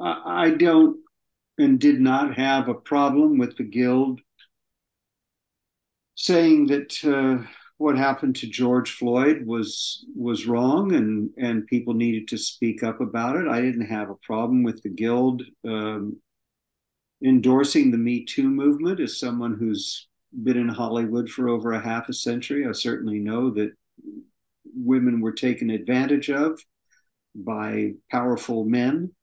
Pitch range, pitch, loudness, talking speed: 115-160 Hz, 125 Hz, -23 LUFS, 140 wpm